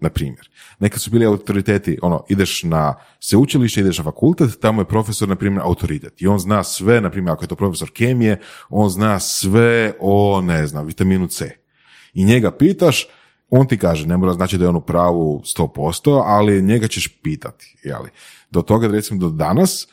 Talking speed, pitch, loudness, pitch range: 190 wpm, 100 Hz, -17 LUFS, 90-110 Hz